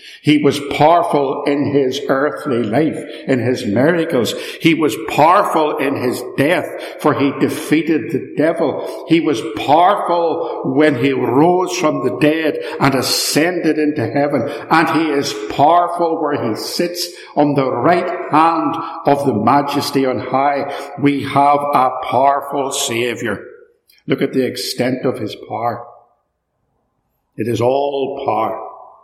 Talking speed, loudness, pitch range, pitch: 135 wpm, -16 LUFS, 135-160 Hz, 145 Hz